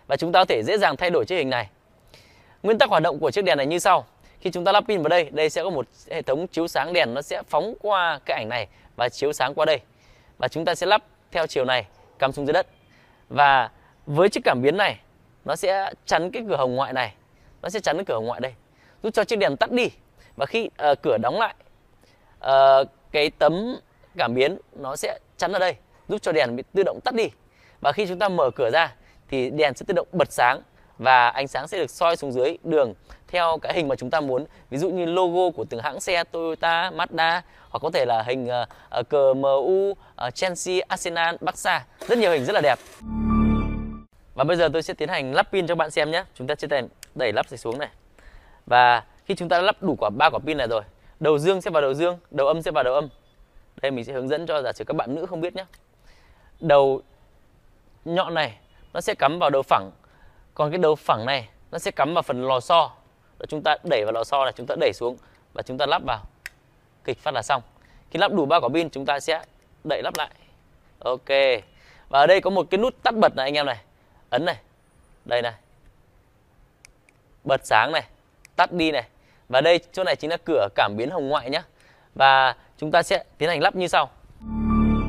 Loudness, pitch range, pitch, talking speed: -23 LUFS, 125-175 Hz, 140 Hz, 235 wpm